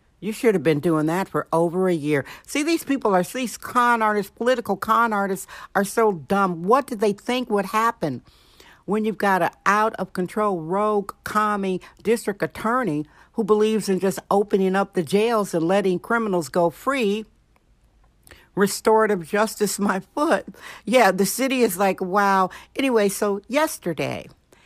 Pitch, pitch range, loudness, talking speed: 205 Hz, 185-225 Hz, -22 LUFS, 160 wpm